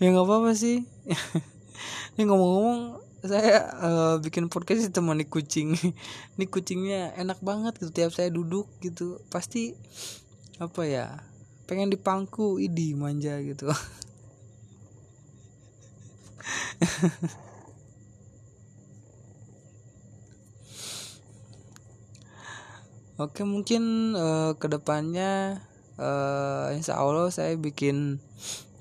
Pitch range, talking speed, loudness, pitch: 115-180 Hz, 85 wpm, -28 LUFS, 145 Hz